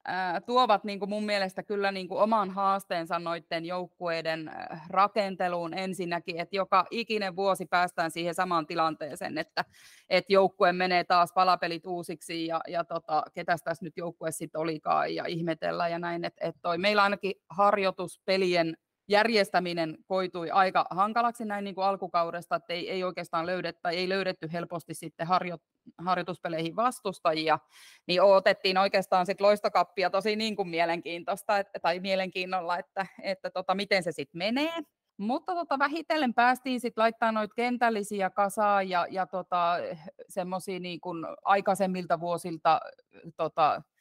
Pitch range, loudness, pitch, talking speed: 170-200 Hz, -29 LUFS, 185 Hz, 140 wpm